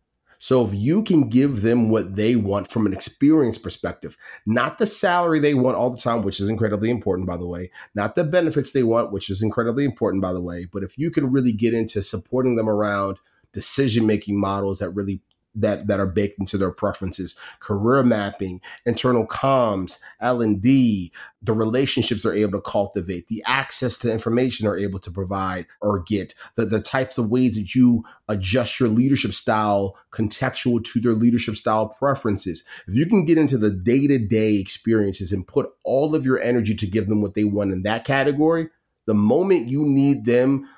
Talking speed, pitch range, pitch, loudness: 190 wpm, 100-130 Hz, 110 Hz, -21 LUFS